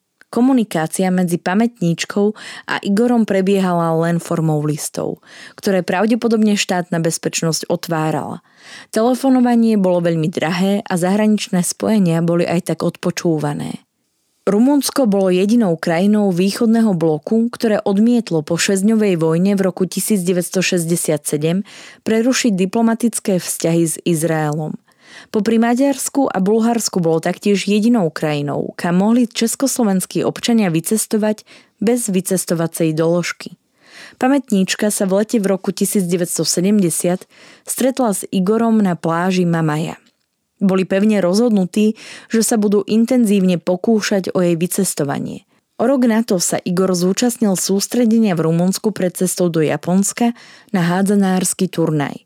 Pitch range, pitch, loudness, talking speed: 175-220 Hz, 195 Hz, -16 LUFS, 115 wpm